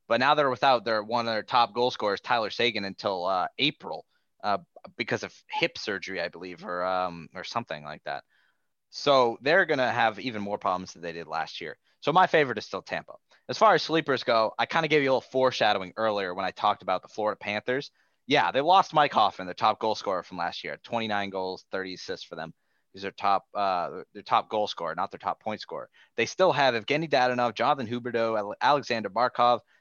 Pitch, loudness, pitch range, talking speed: 115 Hz, -27 LUFS, 100-130 Hz, 215 wpm